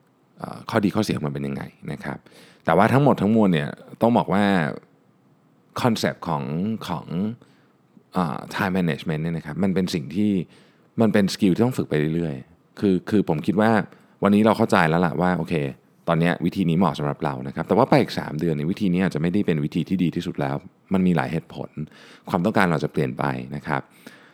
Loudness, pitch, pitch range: -22 LUFS, 85 Hz, 75-95 Hz